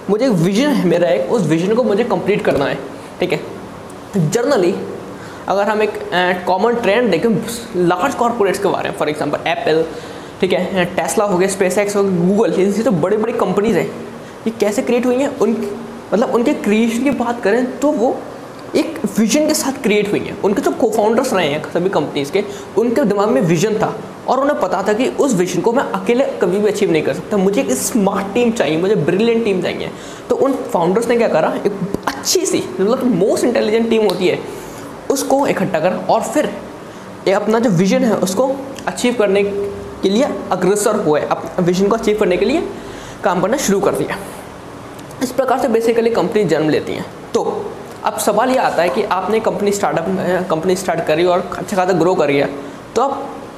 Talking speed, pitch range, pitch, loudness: 205 wpm, 185-235 Hz, 205 Hz, -16 LUFS